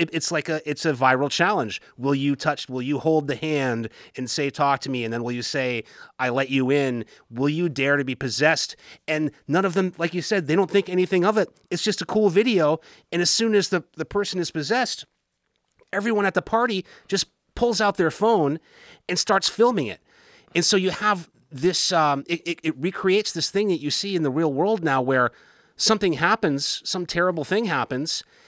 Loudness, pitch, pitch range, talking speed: -23 LUFS, 170 Hz, 145-195 Hz, 215 wpm